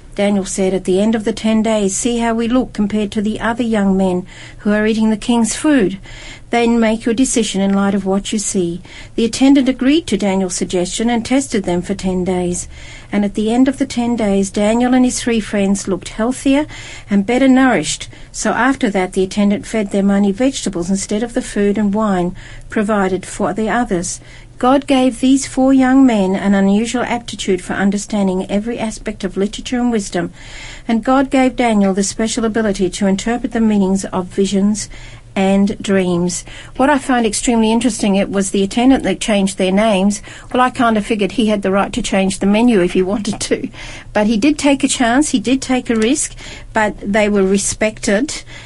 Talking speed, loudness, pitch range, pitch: 200 wpm, -15 LUFS, 195-240 Hz, 215 Hz